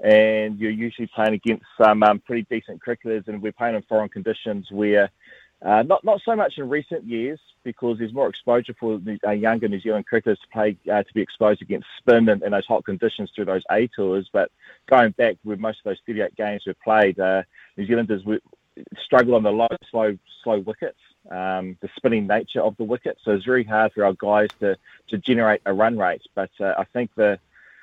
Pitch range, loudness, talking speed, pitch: 105-115 Hz, -22 LUFS, 210 wpm, 110 Hz